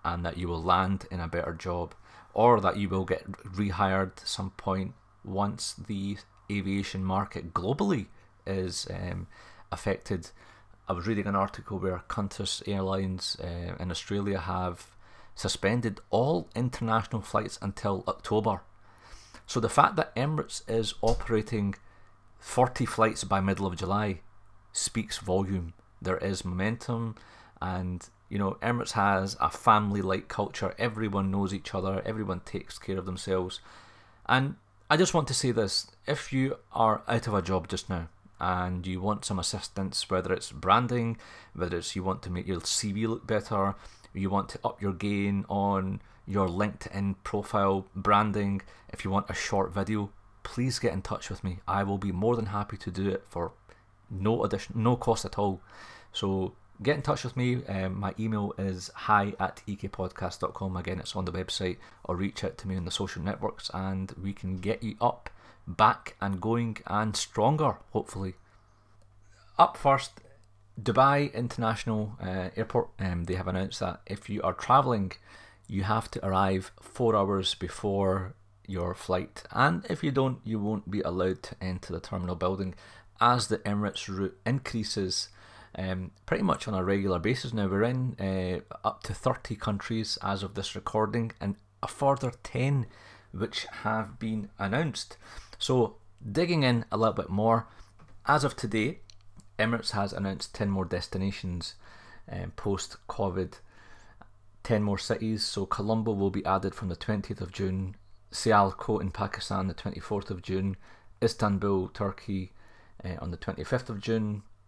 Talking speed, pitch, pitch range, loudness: 160 wpm, 100 Hz, 95-110 Hz, -30 LUFS